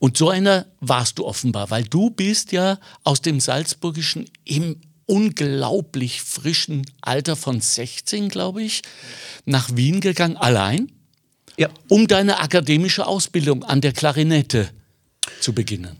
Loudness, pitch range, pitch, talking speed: -20 LUFS, 130-185 Hz, 150 Hz, 130 wpm